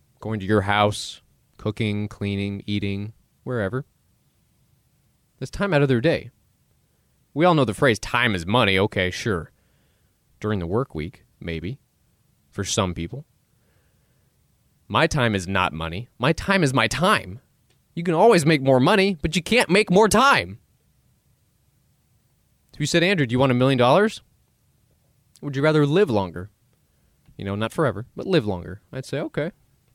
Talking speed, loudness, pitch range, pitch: 160 wpm, -21 LUFS, 100-150 Hz, 120 Hz